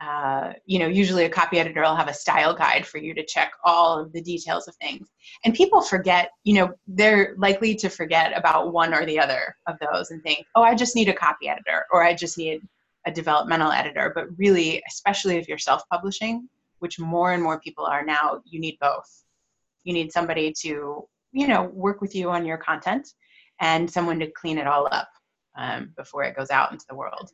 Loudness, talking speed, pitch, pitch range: -22 LUFS, 215 wpm, 170 Hz, 160-195 Hz